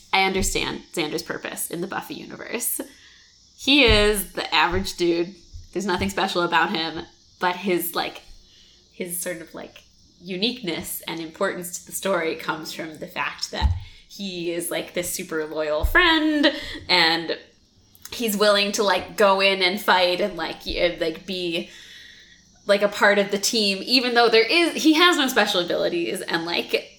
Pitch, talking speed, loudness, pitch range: 185 Hz, 160 wpm, -21 LUFS, 170-210 Hz